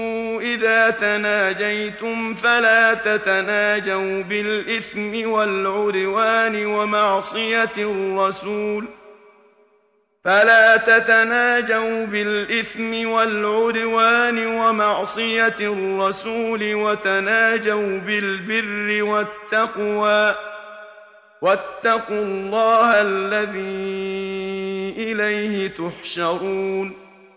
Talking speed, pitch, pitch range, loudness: 40 wpm, 210 Hz, 195-225 Hz, -19 LUFS